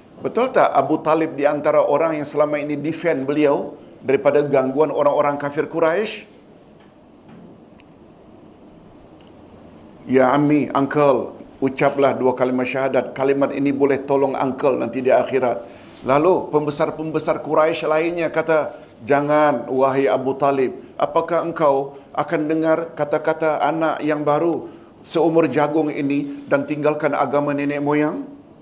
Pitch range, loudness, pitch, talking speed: 140-155 Hz, -19 LUFS, 145 Hz, 120 wpm